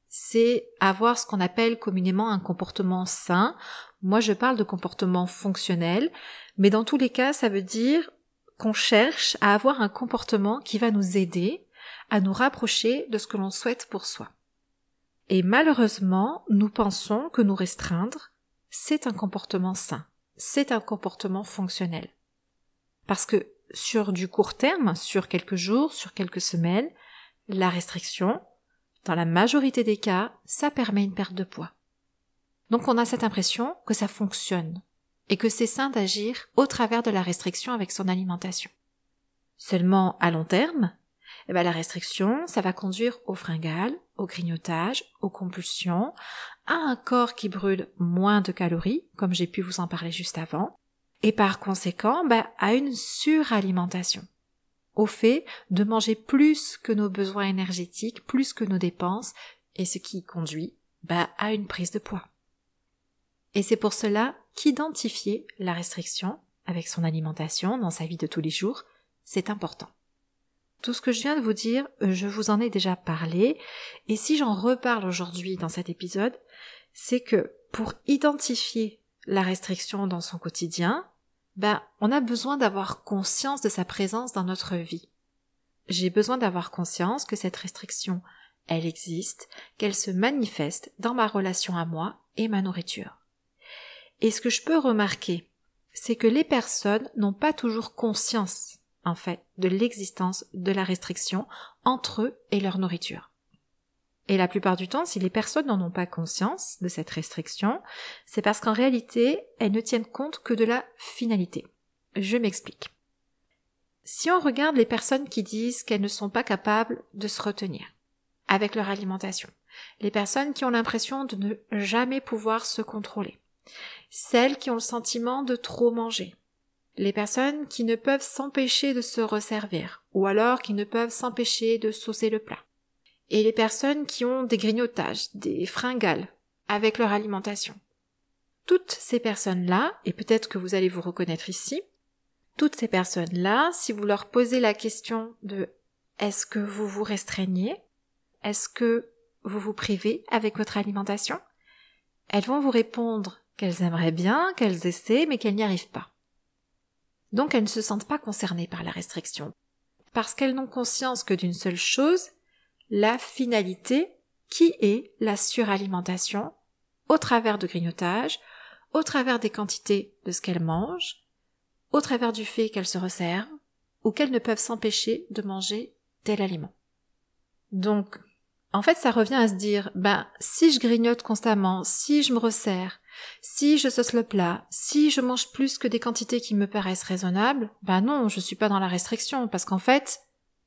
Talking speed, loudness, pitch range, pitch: 165 wpm, -26 LUFS, 185-240 Hz, 210 Hz